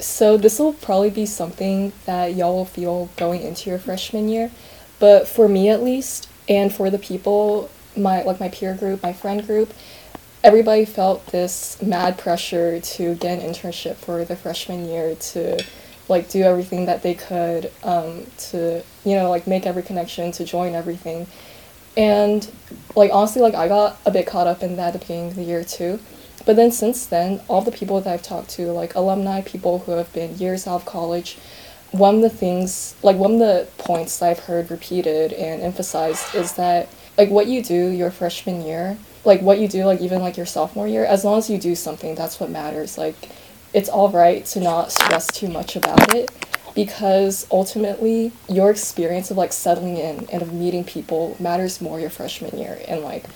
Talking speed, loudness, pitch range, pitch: 195 wpm, -19 LUFS, 175-205 Hz, 185 Hz